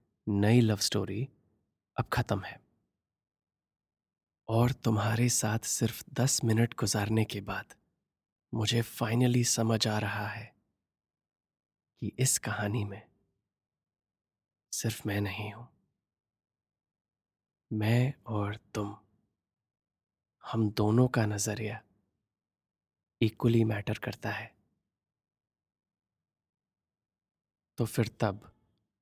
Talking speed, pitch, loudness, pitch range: 90 wpm, 110 Hz, -31 LUFS, 105-115 Hz